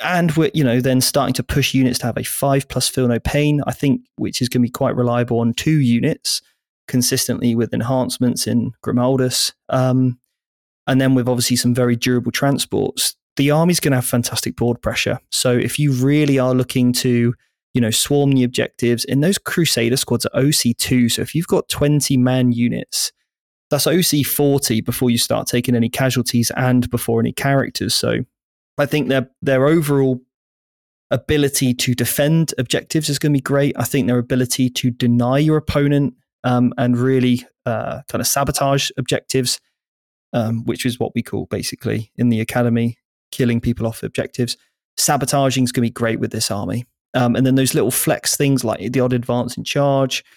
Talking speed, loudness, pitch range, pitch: 185 wpm, -18 LUFS, 120-140 Hz, 125 Hz